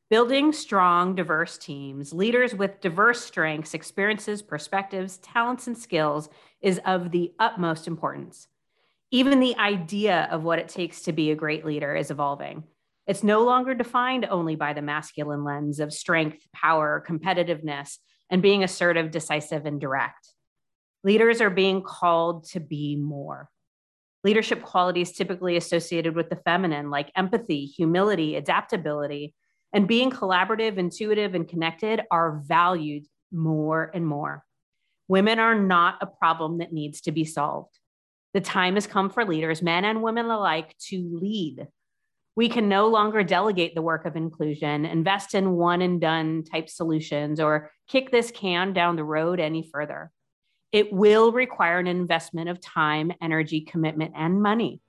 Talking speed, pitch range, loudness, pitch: 150 wpm, 155-200 Hz, -24 LUFS, 175 Hz